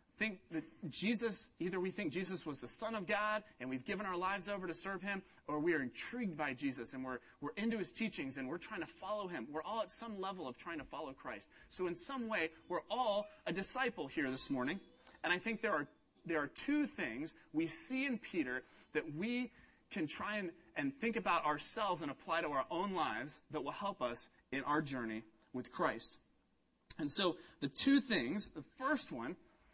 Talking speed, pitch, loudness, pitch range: 210 wpm, 185 Hz, -40 LUFS, 150-225 Hz